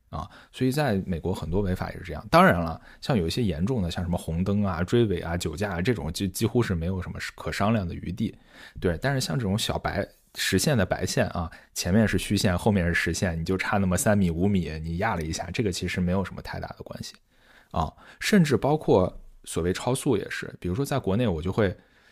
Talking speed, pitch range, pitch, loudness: 335 characters per minute, 90-110 Hz, 95 Hz, -26 LUFS